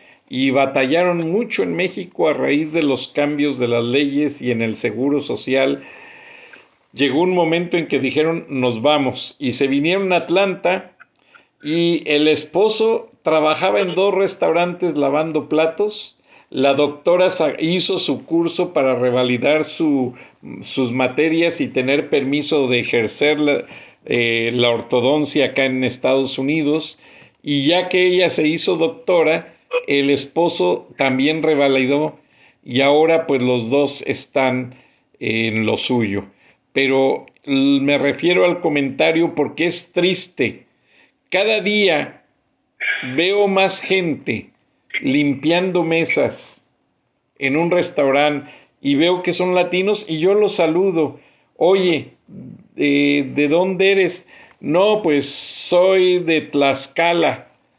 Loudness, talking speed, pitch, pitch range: -17 LUFS, 125 wpm, 150 Hz, 135-175 Hz